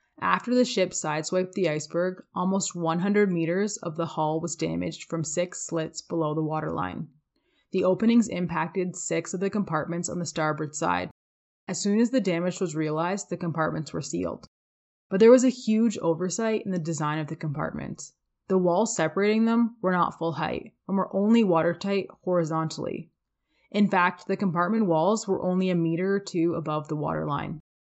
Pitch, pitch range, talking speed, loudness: 175 Hz, 160-195 Hz, 175 wpm, -26 LUFS